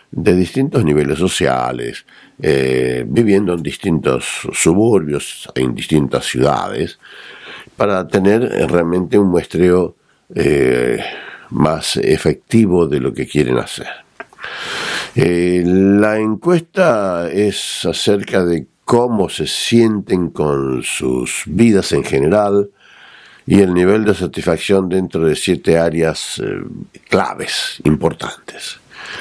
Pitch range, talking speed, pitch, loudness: 75-105 Hz, 105 wpm, 90 Hz, -15 LUFS